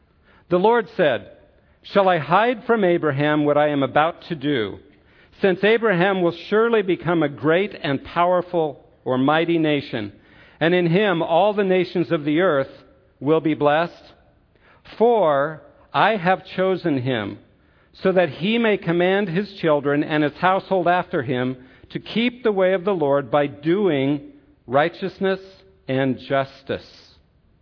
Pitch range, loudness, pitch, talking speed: 140-185 Hz, -20 LUFS, 165 Hz, 145 wpm